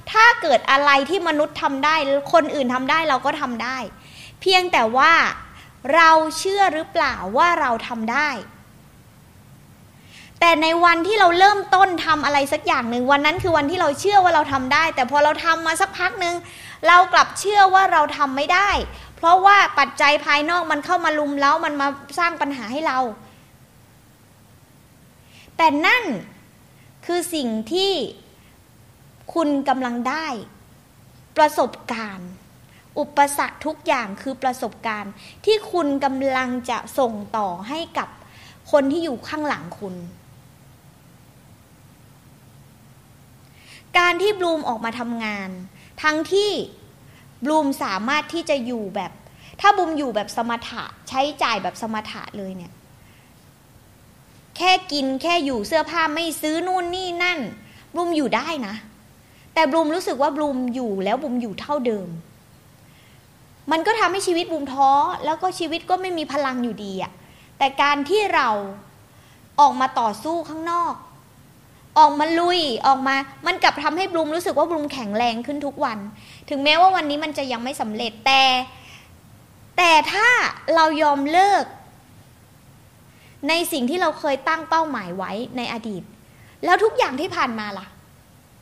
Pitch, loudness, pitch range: 290 Hz, -19 LUFS, 235-330 Hz